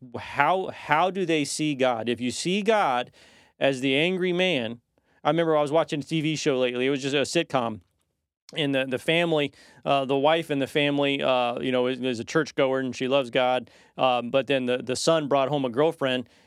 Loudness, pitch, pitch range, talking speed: -25 LUFS, 135 Hz, 125-155 Hz, 215 wpm